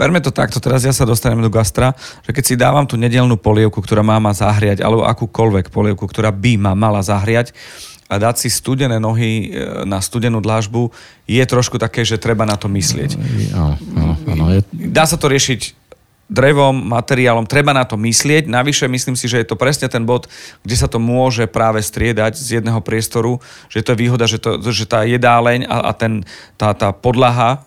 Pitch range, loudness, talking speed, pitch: 110-125 Hz, -15 LUFS, 190 wpm, 115 Hz